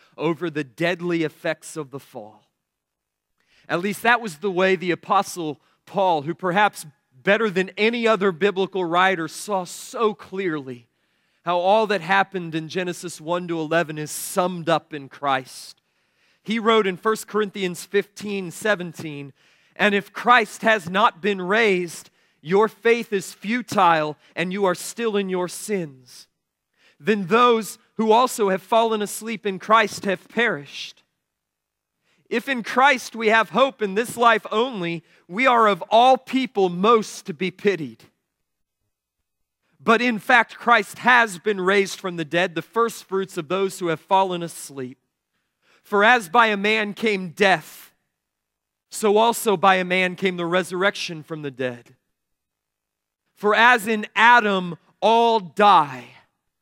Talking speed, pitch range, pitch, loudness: 145 wpm, 170-220 Hz, 195 Hz, -21 LUFS